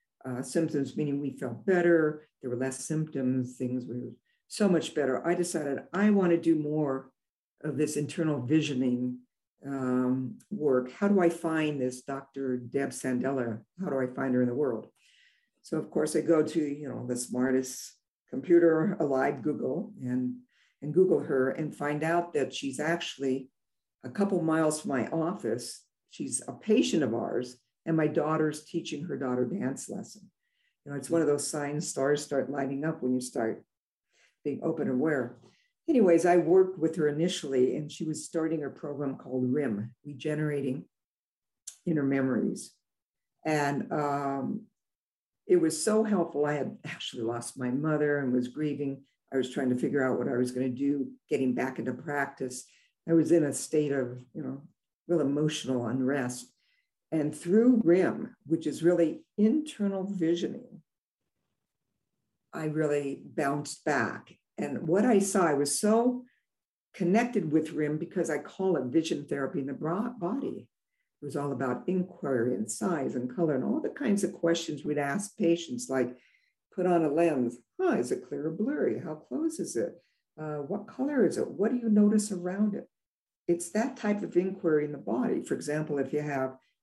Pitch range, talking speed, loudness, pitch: 130-175 Hz, 175 wpm, -30 LUFS, 150 Hz